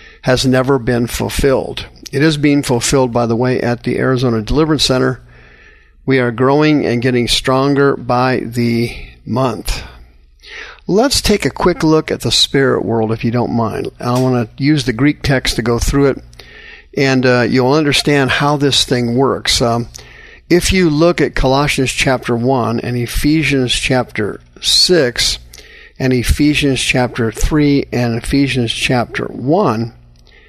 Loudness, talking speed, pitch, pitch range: -14 LUFS, 150 wpm, 125 Hz, 120-140 Hz